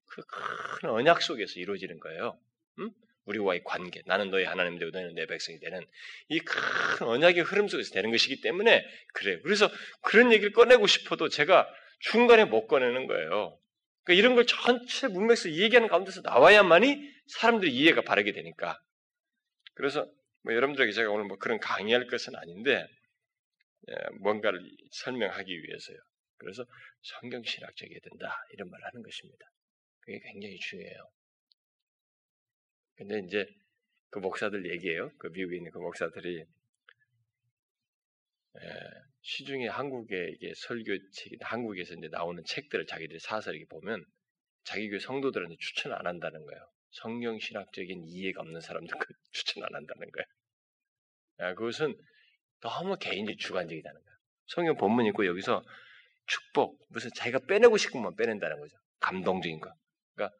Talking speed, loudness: 340 characters per minute, -27 LUFS